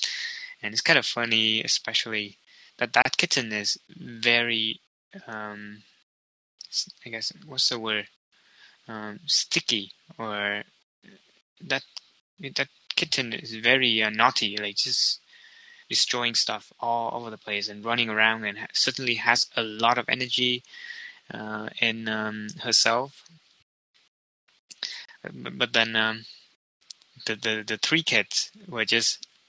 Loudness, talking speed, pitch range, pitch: -25 LUFS, 125 wpm, 110-125 Hz, 115 Hz